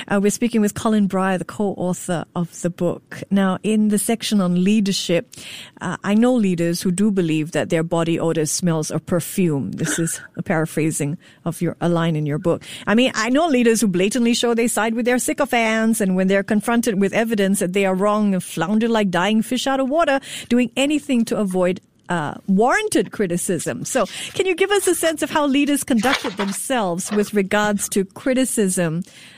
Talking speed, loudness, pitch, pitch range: 195 wpm, -19 LUFS, 200 Hz, 175-235 Hz